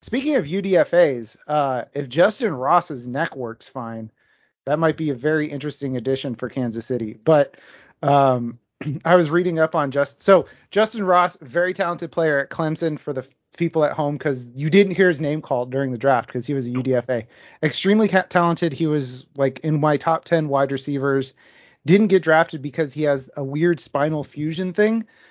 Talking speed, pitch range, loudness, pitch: 185 wpm, 135-170 Hz, -21 LUFS, 150 Hz